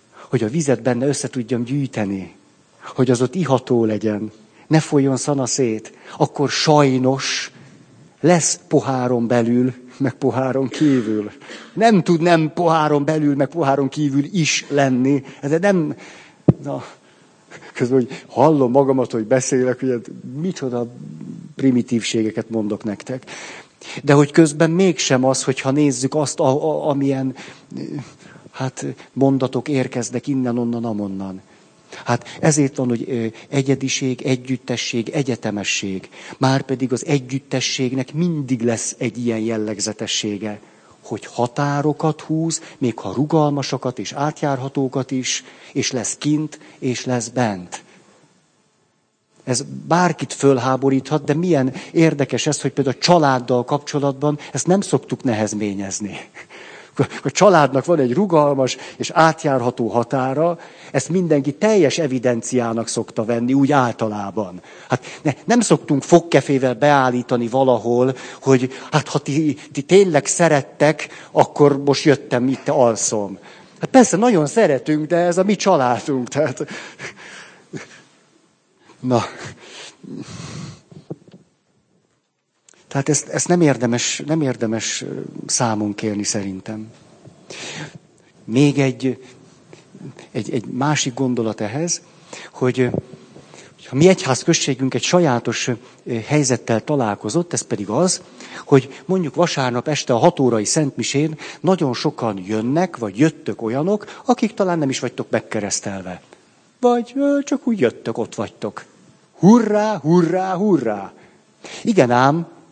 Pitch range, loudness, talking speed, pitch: 120-155 Hz, -19 LUFS, 115 wpm, 135 Hz